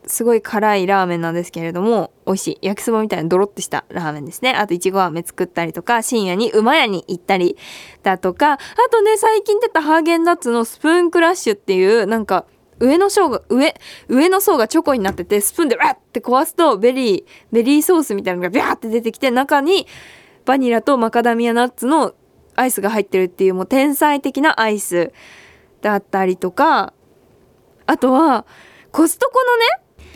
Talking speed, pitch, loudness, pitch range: 400 characters per minute, 235 Hz, -16 LUFS, 195-320 Hz